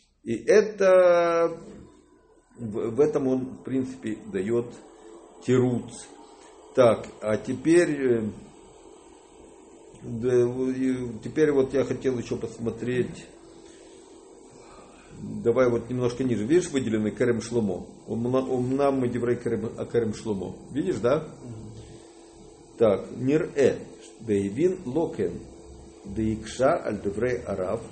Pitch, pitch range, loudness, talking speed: 125 Hz, 115-170 Hz, -25 LUFS, 90 wpm